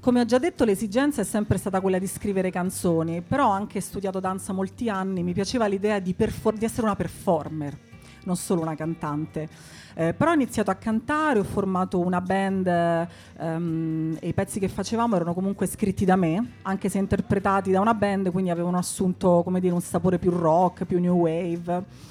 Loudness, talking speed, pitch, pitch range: -25 LUFS, 195 wpm, 190 Hz, 175-200 Hz